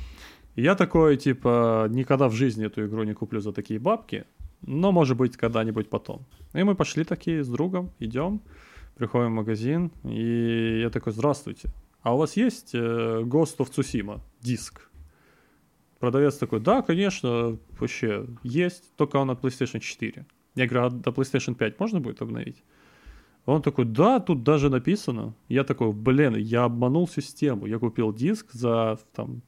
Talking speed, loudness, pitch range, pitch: 155 wpm, -25 LUFS, 115-150 Hz, 125 Hz